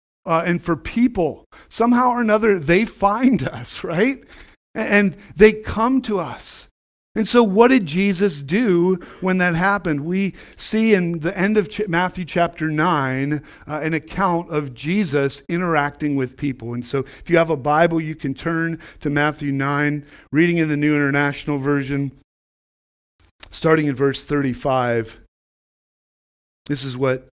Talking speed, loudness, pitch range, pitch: 150 wpm, -19 LUFS, 140-195 Hz, 160 Hz